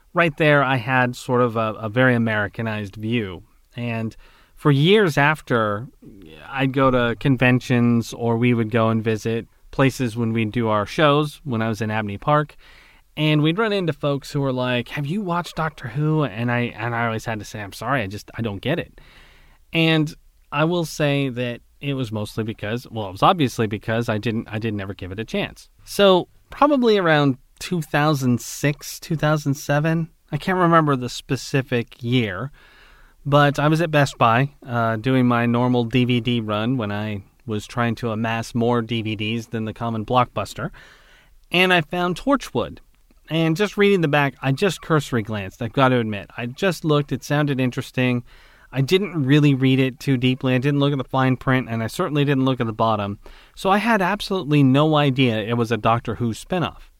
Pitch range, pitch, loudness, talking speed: 115-150 Hz, 130 Hz, -21 LUFS, 195 wpm